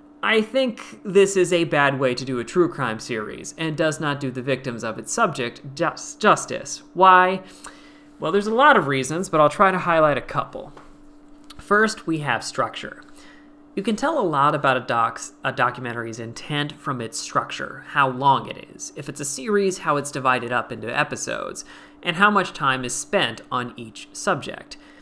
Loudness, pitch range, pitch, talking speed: -21 LUFS, 130-205 Hz, 155 Hz, 185 wpm